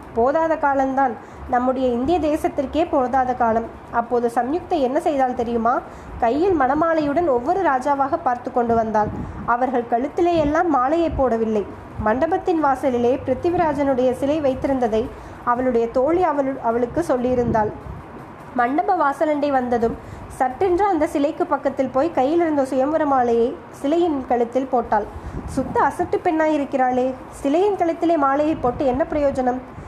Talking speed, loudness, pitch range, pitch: 115 wpm, -20 LUFS, 250-320 Hz, 275 Hz